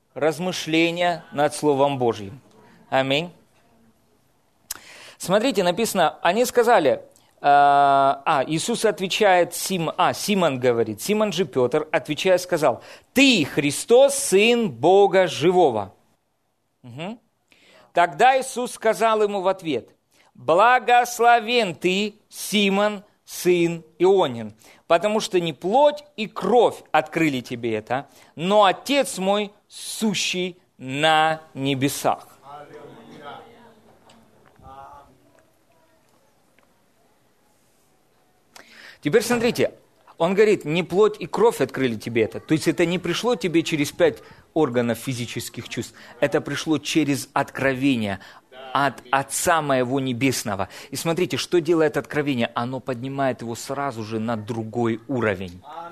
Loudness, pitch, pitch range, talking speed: -21 LUFS, 160 Hz, 135-195 Hz, 105 wpm